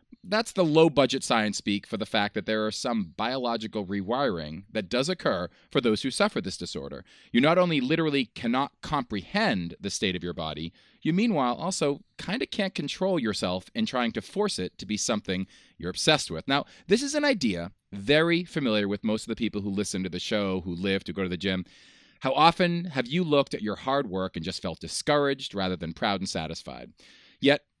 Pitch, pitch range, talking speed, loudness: 110 Hz, 95-160 Hz, 210 wpm, -27 LUFS